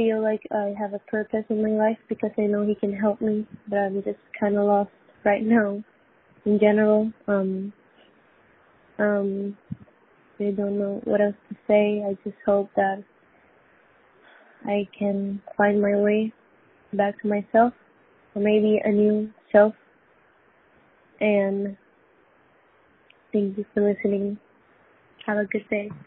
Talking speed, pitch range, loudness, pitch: 145 wpm, 200-215 Hz, -24 LUFS, 210 Hz